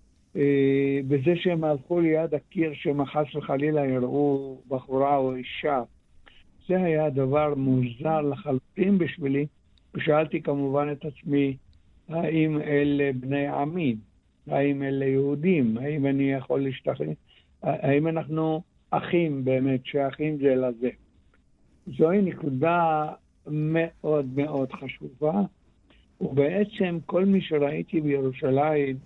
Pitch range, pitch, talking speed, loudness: 135-155 Hz, 145 Hz, 105 wpm, -26 LUFS